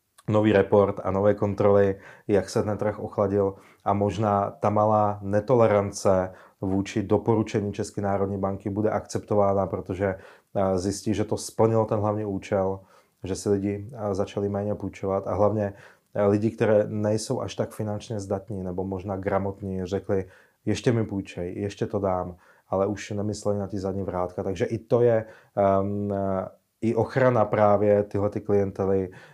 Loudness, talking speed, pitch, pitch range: -25 LUFS, 150 wpm, 100 Hz, 95-105 Hz